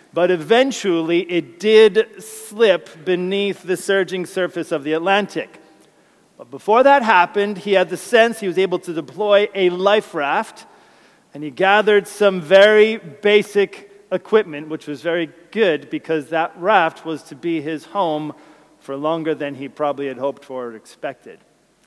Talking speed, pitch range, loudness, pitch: 155 wpm, 160-205 Hz, -17 LUFS, 180 Hz